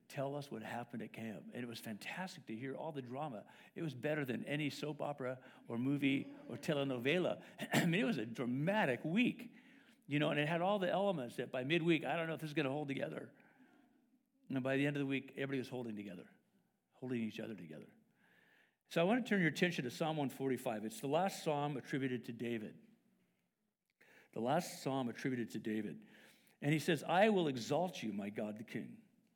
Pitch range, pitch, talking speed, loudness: 125-180 Hz, 145 Hz, 210 wpm, -39 LUFS